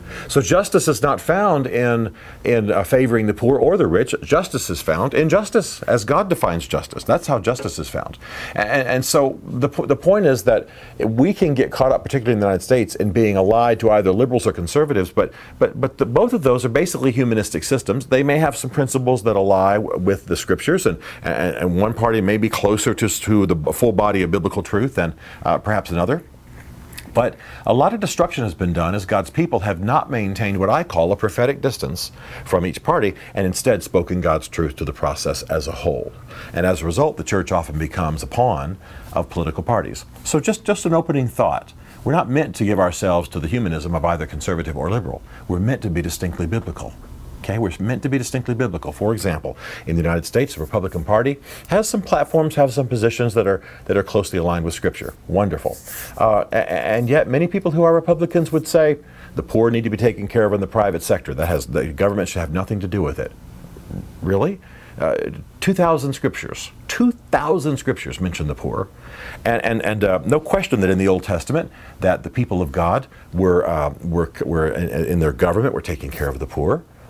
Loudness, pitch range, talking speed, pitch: -19 LUFS, 90-130 Hz, 210 wpm, 105 Hz